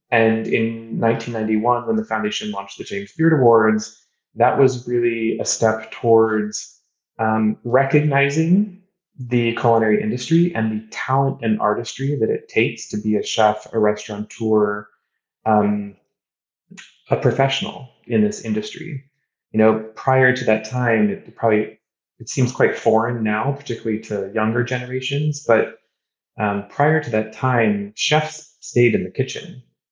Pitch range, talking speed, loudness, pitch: 110-135 Hz, 140 wpm, -19 LUFS, 115 Hz